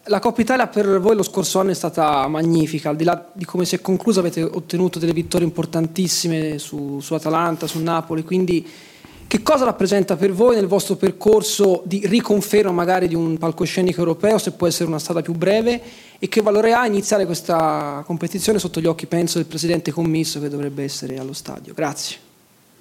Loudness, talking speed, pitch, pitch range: -19 LUFS, 190 wpm, 175 Hz, 165-200 Hz